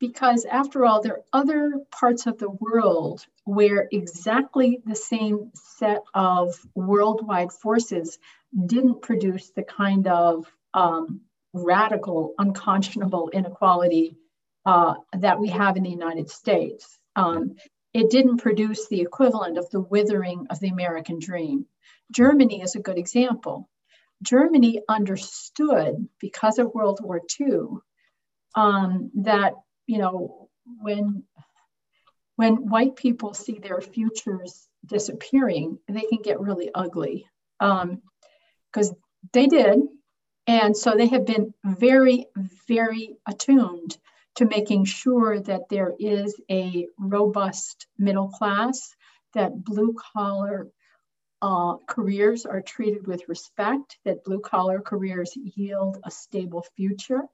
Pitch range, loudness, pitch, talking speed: 190-230 Hz, -23 LUFS, 205 Hz, 120 wpm